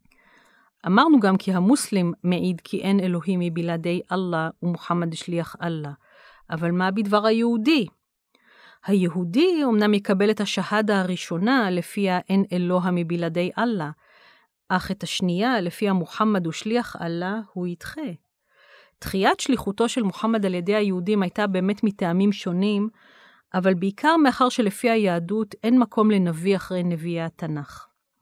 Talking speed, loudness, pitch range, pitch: 130 wpm, -23 LUFS, 175-215 Hz, 190 Hz